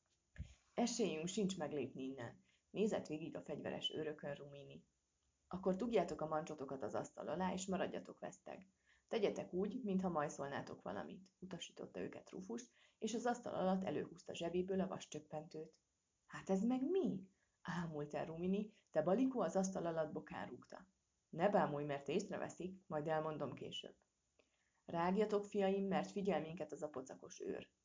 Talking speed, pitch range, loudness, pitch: 140 wpm, 150-200 Hz, -43 LUFS, 175 Hz